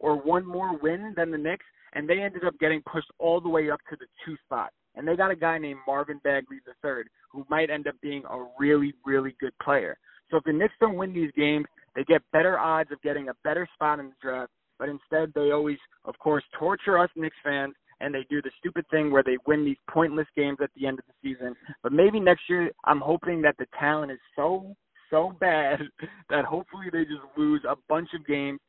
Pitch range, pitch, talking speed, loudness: 140-170 Hz, 150 Hz, 230 wpm, -27 LUFS